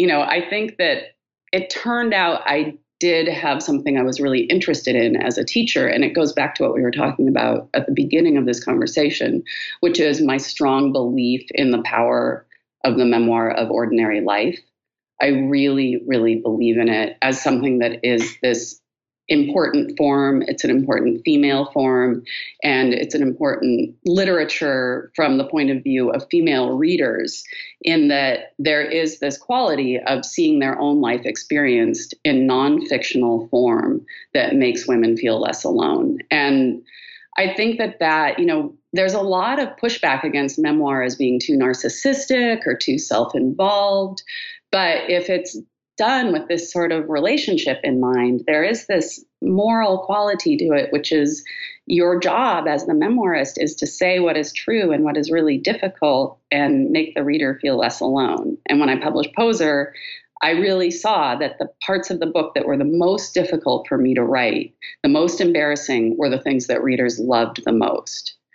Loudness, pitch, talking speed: -19 LUFS, 165 Hz, 175 wpm